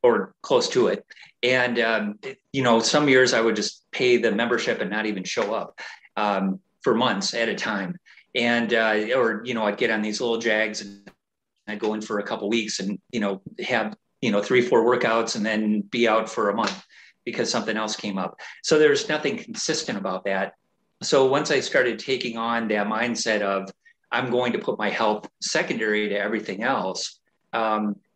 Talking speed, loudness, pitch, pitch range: 200 wpm, -23 LUFS, 115 Hz, 105-125 Hz